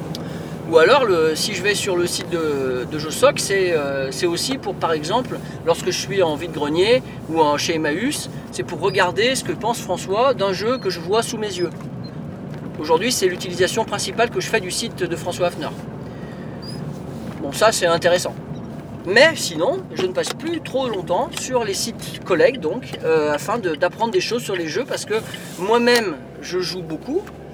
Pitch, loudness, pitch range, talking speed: 185 Hz, -20 LUFS, 170-230 Hz, 195 wpm